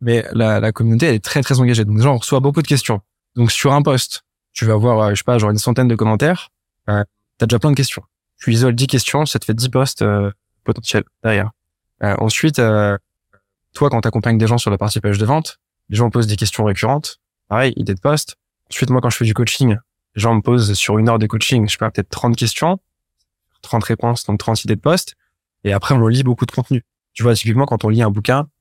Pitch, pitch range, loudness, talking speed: 115 Hz, 105-125 Hz, -16 LUFS, 250 wpm